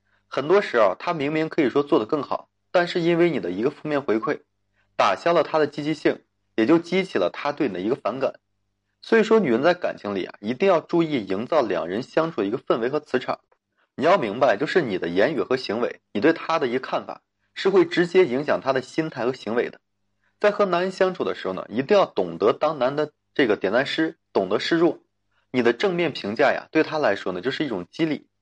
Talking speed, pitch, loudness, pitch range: 330 characters per minute, 155 Hz, -23 LUFS, 120-175 Hz